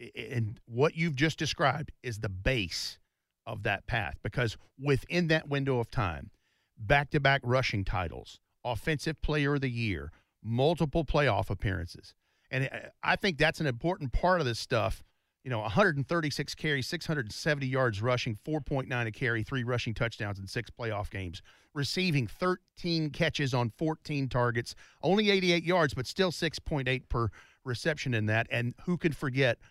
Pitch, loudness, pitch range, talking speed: 130 Hz, -31 LUFS, 115-155 Hz, 150 wpm